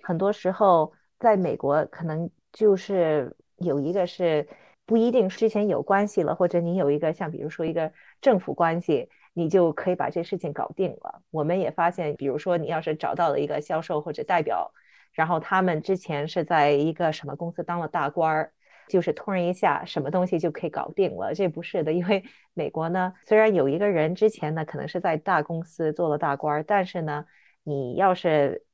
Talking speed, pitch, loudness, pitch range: 300 characters per minute, 170 Hz, -25 LUFS, 155-190 Hz